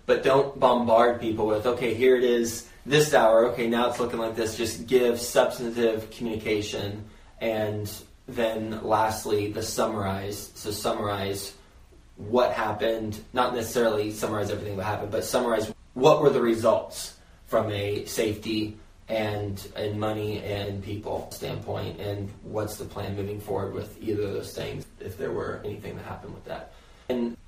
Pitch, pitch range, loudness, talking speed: 110 Hz, 100-115 Hz, -26 LUFS, 155 wpm